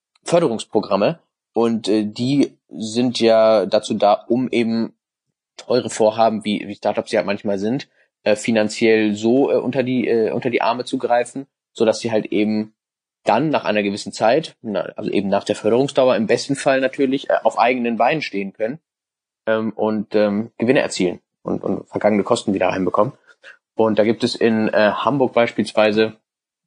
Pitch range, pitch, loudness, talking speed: 105-120 Hz, 110 Hz, -19 LUFS, 165 wpm